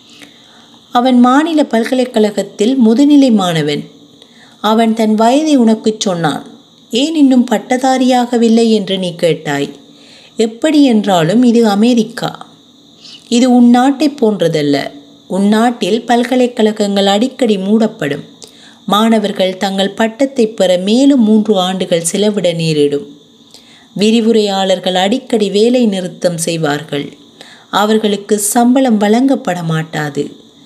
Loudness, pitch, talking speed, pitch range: -12 LUFS, 225 Hz, 90 wpm, 190-250 Hz